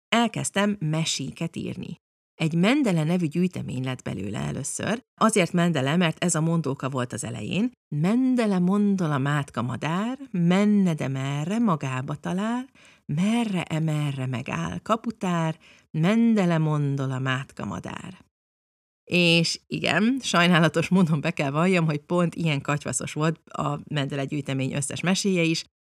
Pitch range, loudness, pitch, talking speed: 145-195 Hz, -25 LUFS, 165 Hz, 130 wpm